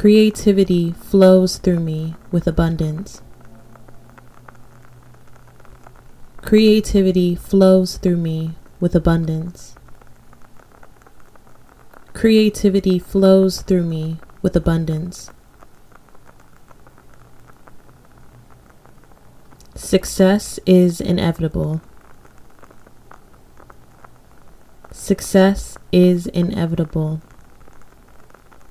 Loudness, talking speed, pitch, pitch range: -16 LUFS, 50 wpm, 175 Hz, 160-190 Hz